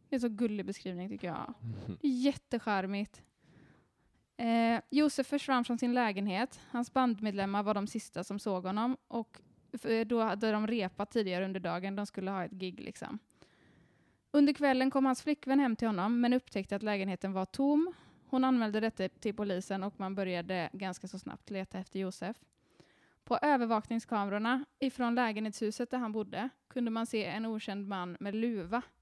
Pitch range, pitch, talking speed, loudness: 195-245 Hz, 220 Hz, 165 wpm, -34 LUFS